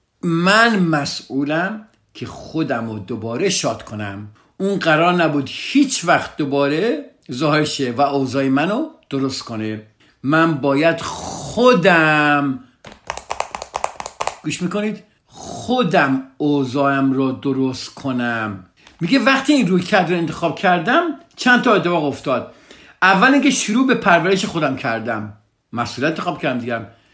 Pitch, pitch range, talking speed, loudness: 155 Hz, 130-195 Hz, 115 wpm, -18 LUFS